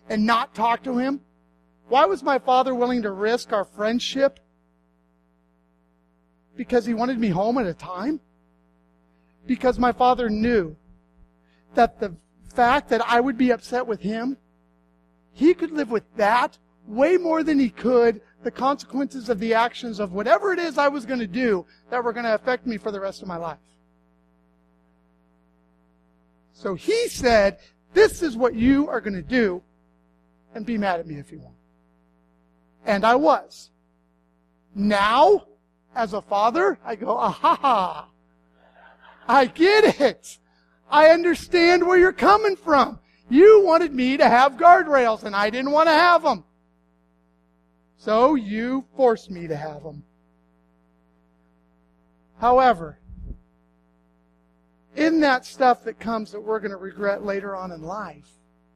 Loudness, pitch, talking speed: -20 LUFS, 205 Hz, 150 wpm